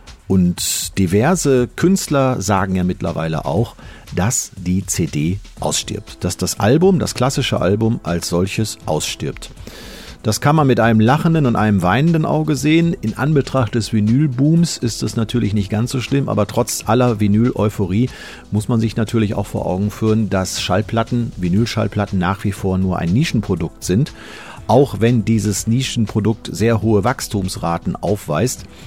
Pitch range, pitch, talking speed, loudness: 95-125 Hz, 110 Hz, 150 wpm, -17 LUFS